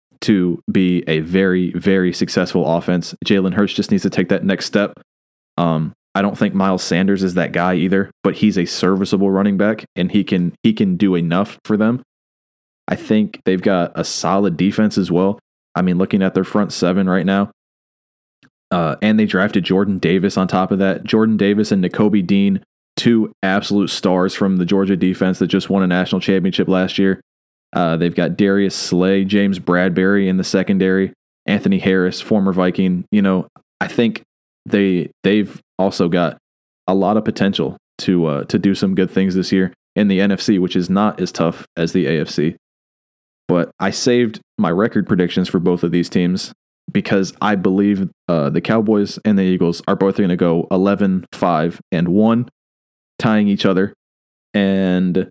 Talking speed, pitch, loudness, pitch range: 185 wpm, 95 Hz, -17 LUFS, 90-100 Hz